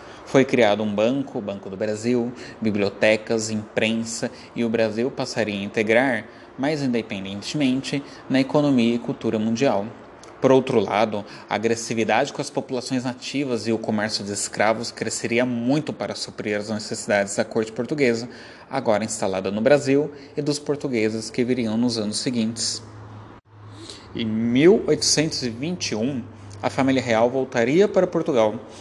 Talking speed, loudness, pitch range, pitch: 135 wpm, -22 LUFS, 110-130 Hz, 115 Hz